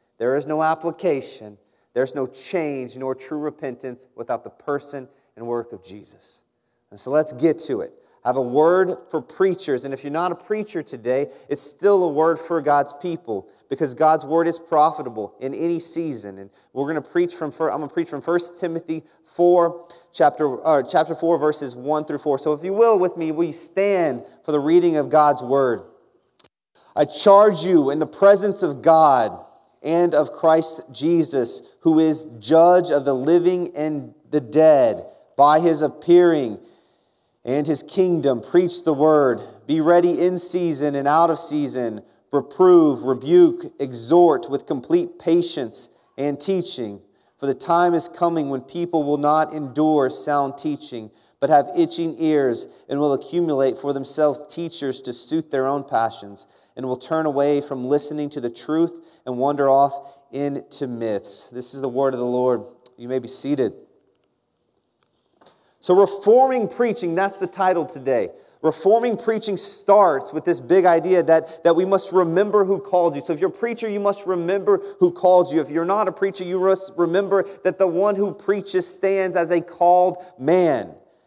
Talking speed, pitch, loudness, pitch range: 175 wpm, 160 Hz, -20 LUFS, 140-180 Hz